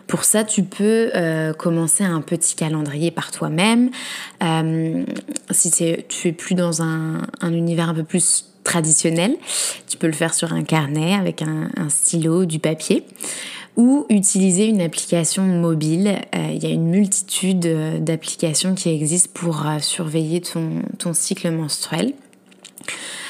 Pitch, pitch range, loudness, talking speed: 170 Hz, 160-195 Hz, -19 LUFS, 150 wpm